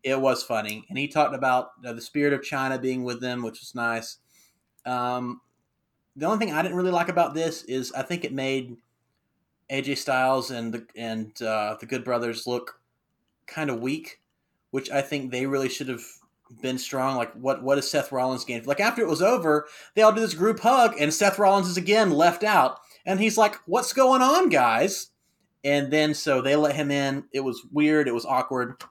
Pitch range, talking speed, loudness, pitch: 125-165 Hz, 210 wpm, -24 LUFS, 135 Hz